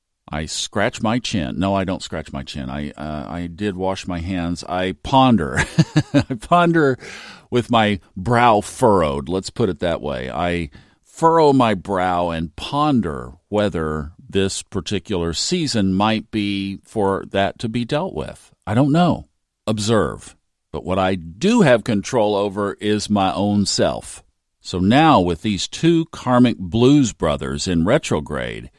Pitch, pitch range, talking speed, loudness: 100 Hz, 85-120 Hz, 150 wpm, -19 LUFS